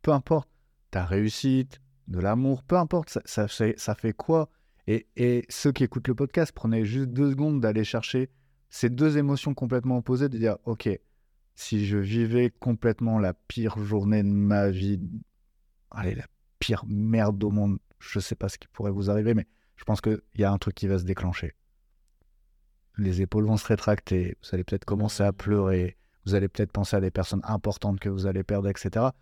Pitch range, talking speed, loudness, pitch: 95-120 Hz, 195 wpm, -27 LUFS, 105 Hz